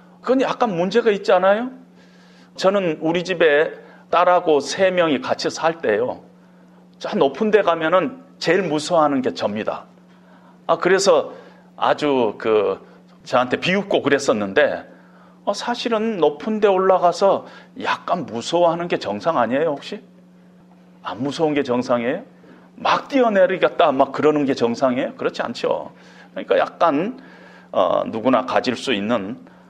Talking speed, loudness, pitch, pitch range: 285 characters per minute, -19 LUFS, 180 Hz, 150-200 Hz